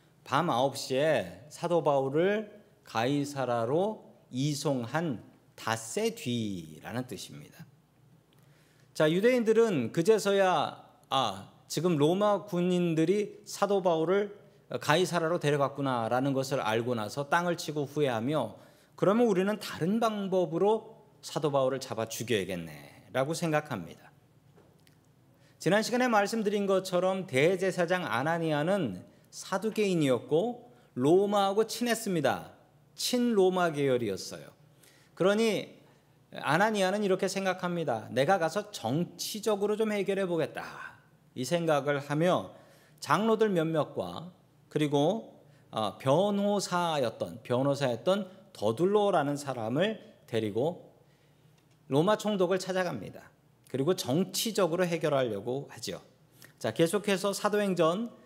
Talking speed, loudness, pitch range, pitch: 260 characters per minute, -29 LUFS, 140-195 Hz, 160 Hz